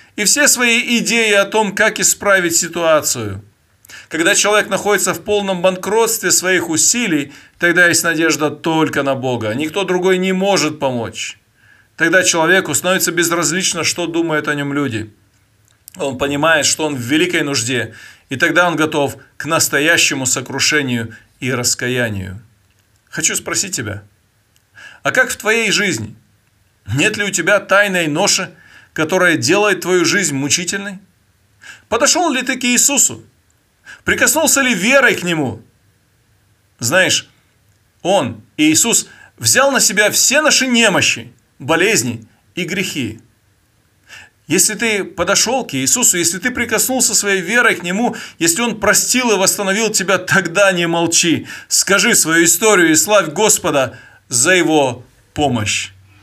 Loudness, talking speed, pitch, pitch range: -14 LUFS, 135 wpm, 170 Hz, 130-205 Hz